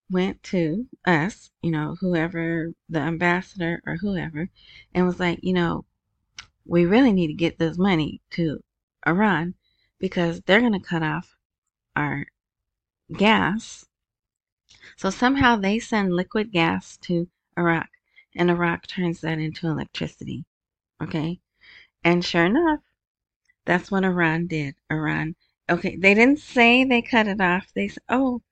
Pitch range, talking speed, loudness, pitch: 165-210 Hz, 140 wpm, -23 LUFS, 180 Hz